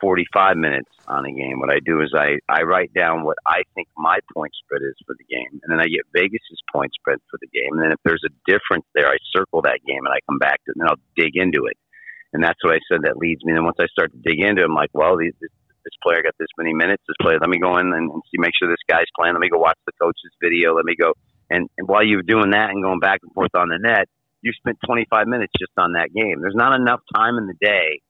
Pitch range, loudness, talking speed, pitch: 85-110 Hz, -19 LUFS, 290 wpm, 95 Hz